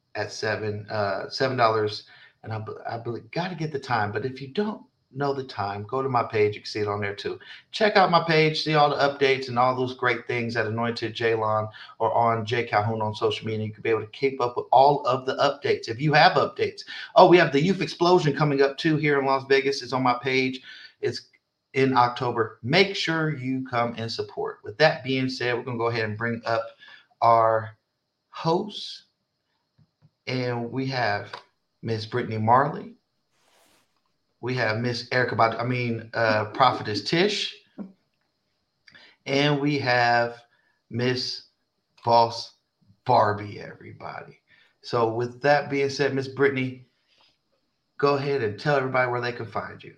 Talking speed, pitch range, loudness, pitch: 180 wpm, 115-145 Hz, -24 LUFS, 125 Hz